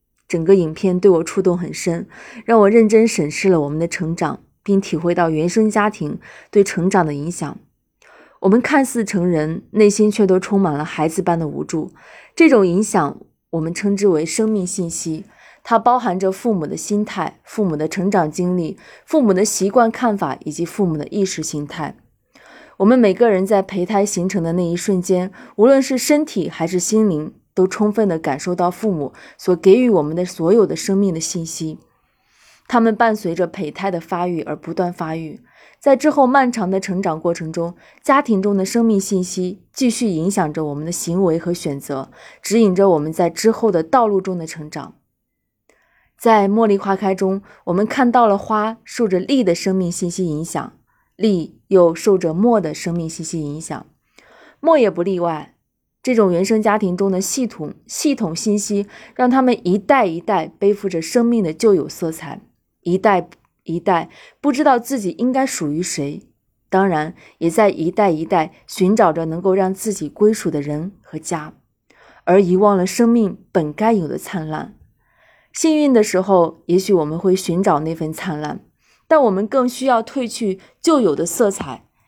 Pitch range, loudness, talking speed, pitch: 170-215 Hz, -17 LUFS, 260 characters per minute, 190 Hz